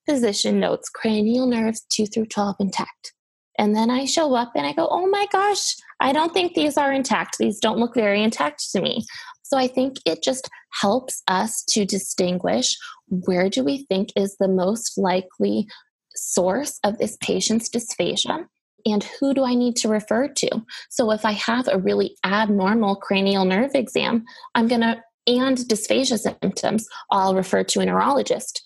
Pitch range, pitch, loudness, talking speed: 200-260 Hz, 225 Hz, -21 LUFS, 175 wpm